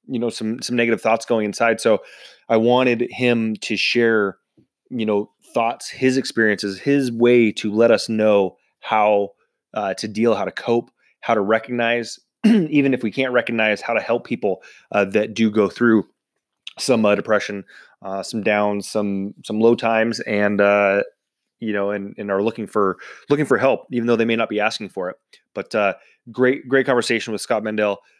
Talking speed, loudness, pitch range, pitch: 185 wpm, -19 LUFS, 105-120 Hz, 115 Hz